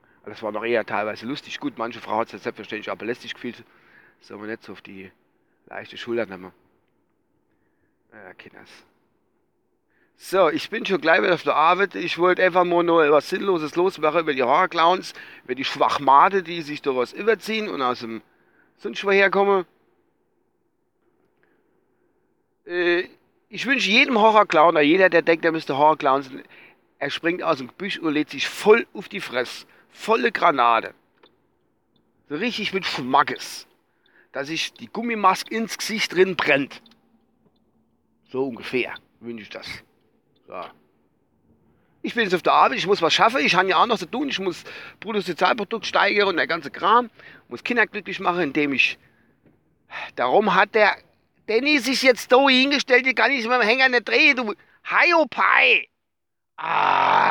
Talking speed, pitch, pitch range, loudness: 165 wpm, 195 Hz, 155-250 Hz, -20 LUFS